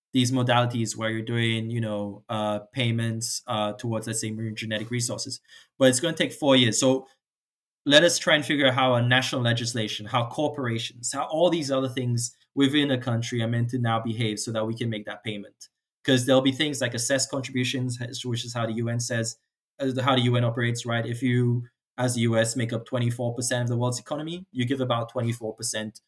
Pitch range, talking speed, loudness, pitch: 115-130 Hz, 205 wpm, -25 LUFS, 120 Hz